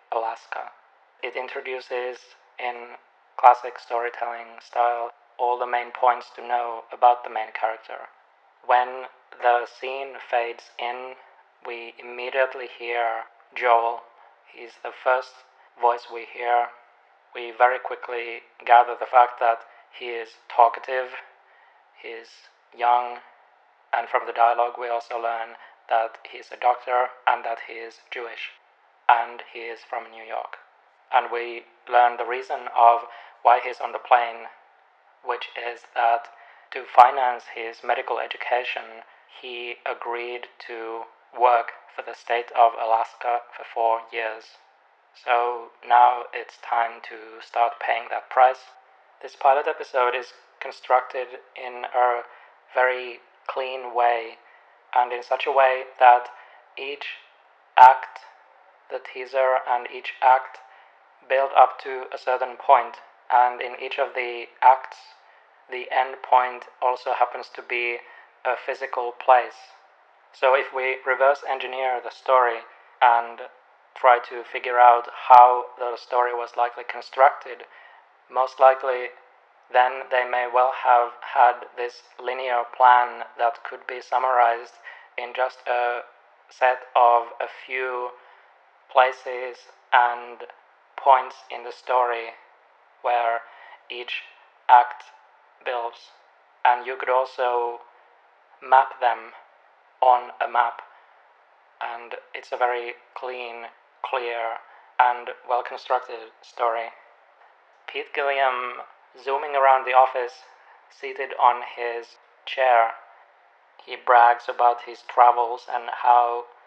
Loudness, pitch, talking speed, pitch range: -22 LUFS, 120 Hz, 120 wpm, 120-125 Hz